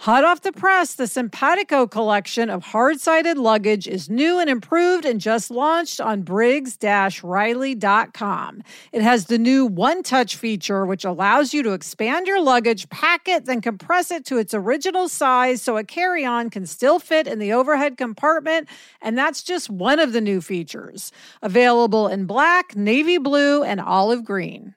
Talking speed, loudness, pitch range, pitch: 160 wpm, -19 LUFS, 215-315 Hz, 245 Hz